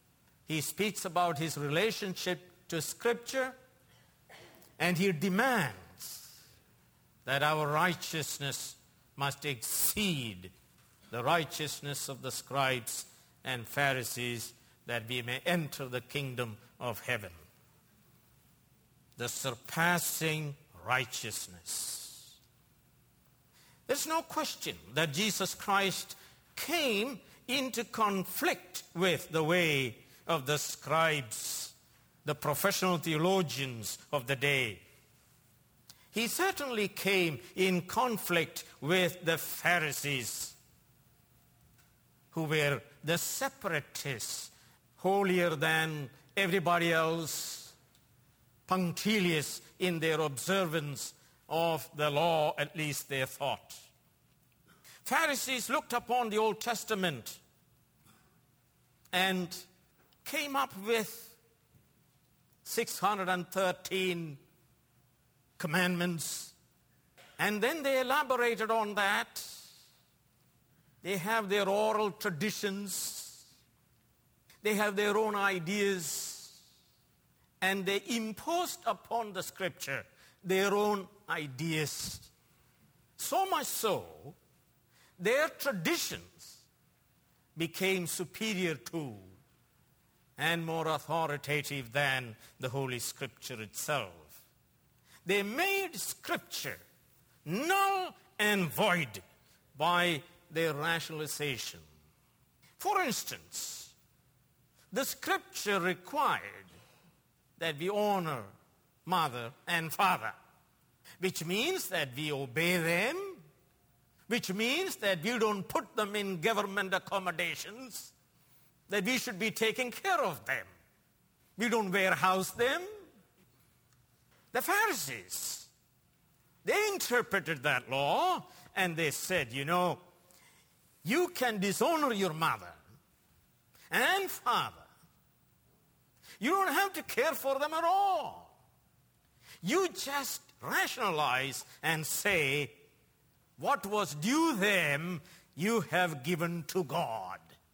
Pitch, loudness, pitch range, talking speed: 175 Hz, -33 LUFS, 145-210 Hz, 90 wpm